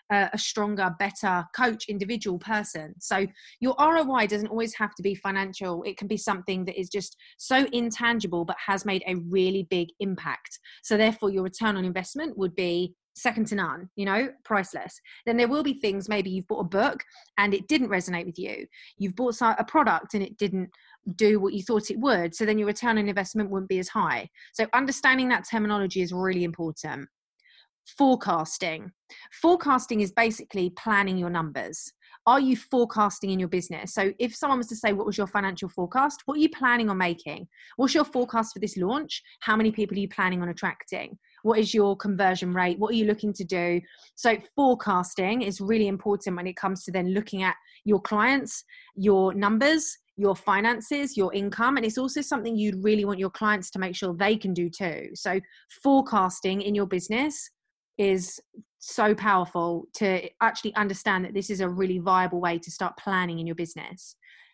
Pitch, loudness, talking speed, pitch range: 205 Hz, -26 LUFS, 190 wpm, 185-230 Hz